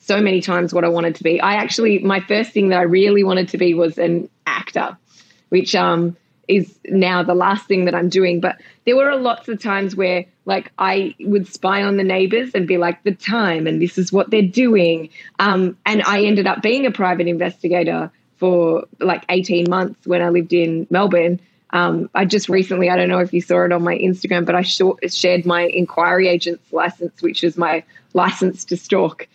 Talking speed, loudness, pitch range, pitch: 210 wpm, -17 LUFS, 175-195 Hz, 180 Hz